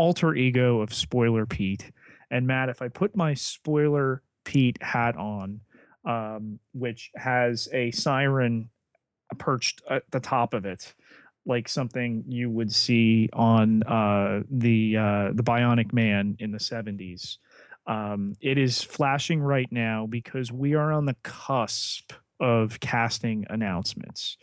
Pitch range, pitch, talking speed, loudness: 110-130 Hz, 120 Hz, 140 wpm, -26 LUFS